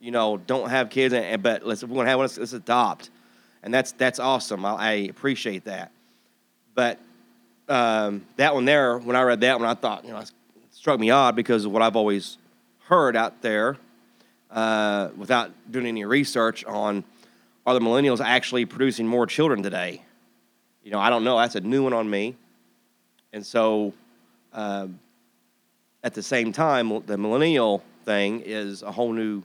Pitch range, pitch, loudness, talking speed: 105-125 Hz, 115 Hz, -23 LUFS, 175 wpm